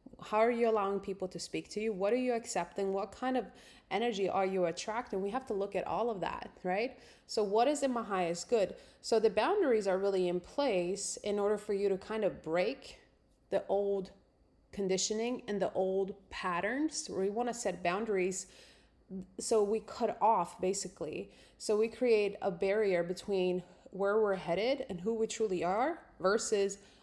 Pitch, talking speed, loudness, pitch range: 200 Hz, 185 wpm, -34 LUFS, 190-225 Hz